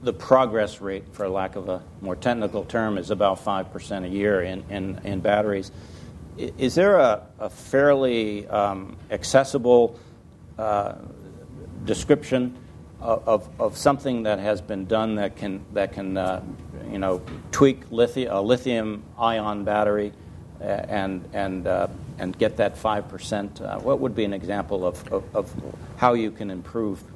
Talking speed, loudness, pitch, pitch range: 155 wpm, -24 LUFS, 105 Hz, 95-120 Hz